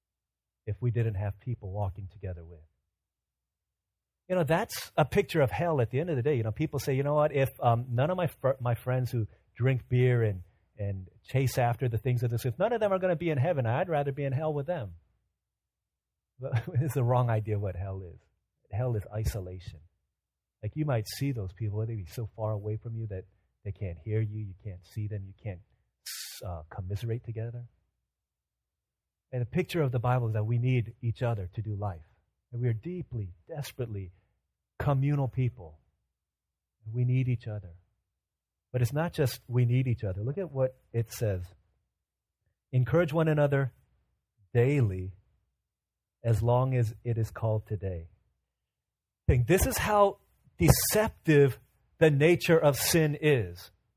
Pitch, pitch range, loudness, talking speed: 115 Hz, 95-130 Hz, -30 LUFS, 180 wpm